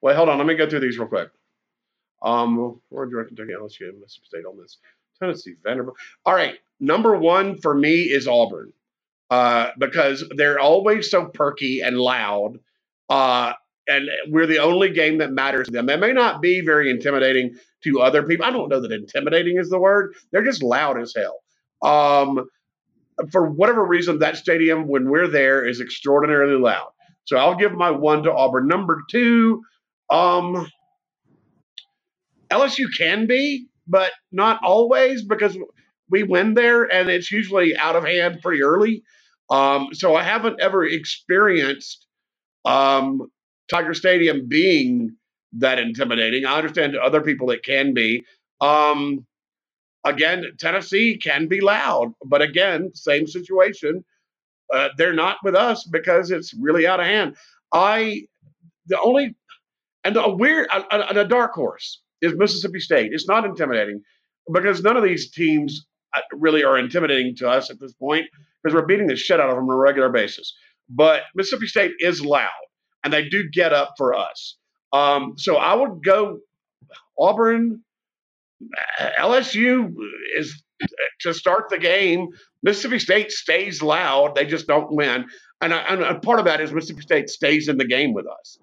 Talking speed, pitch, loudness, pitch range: 160 wpm, 165 Hz, -19 LUFS, 140-200 Hz